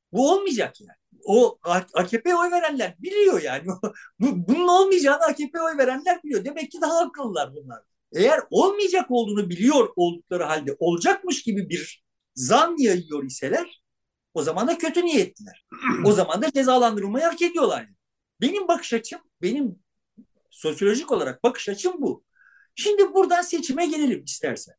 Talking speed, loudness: 140 wpm, -22 LUFS